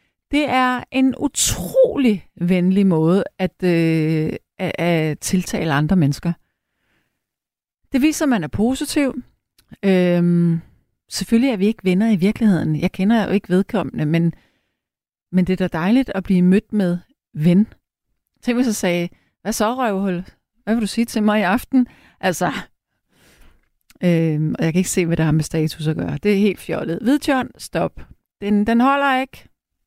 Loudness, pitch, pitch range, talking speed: -19 LUFS, 195 Hz, 175-235 Hz, 165 wpm